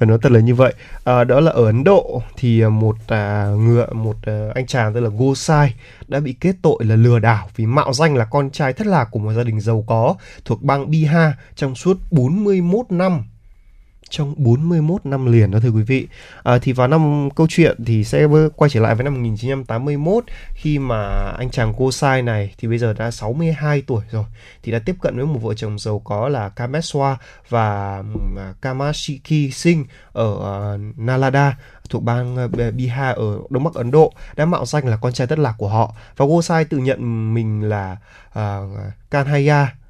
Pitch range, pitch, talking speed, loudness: 110-145 Hz, 125 Hz, 195 wpm, -18 LUFS